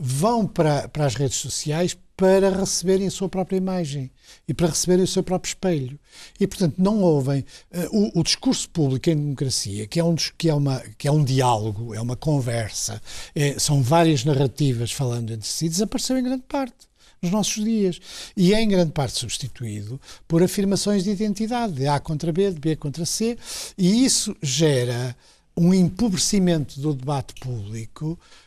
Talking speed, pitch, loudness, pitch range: 175 wpm, 160 Hz, -22 LUFS, 135-190 Hz